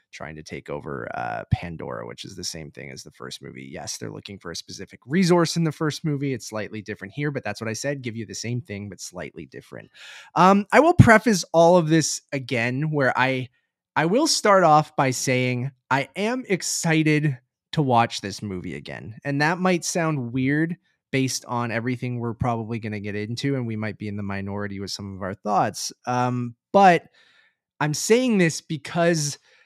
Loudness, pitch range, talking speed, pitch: -22 LUFS, 105-160 Hz, 200 wpm, 130 Hz